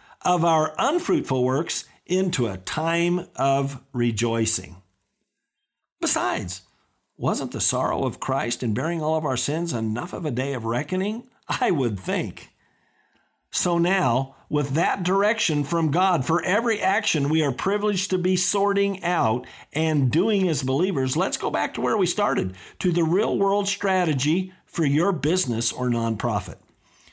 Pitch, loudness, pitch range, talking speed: 160 Hz, -23 LUFS, 125-185 Hz, 150 wpm